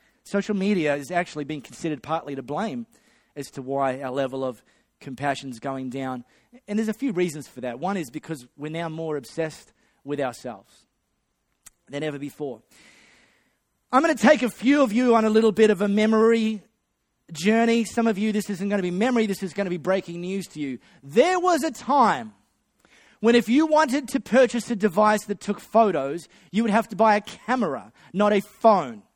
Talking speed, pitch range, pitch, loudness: 200 wpm, 150-225 Hz, 200 Hz, -23 LUFS